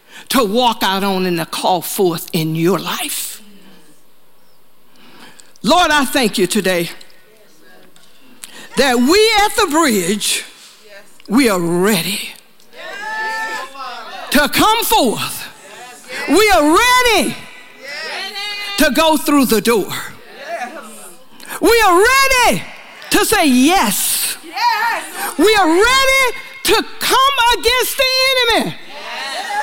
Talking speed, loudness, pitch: 100 wpm, -14 LUFS, 300 Hz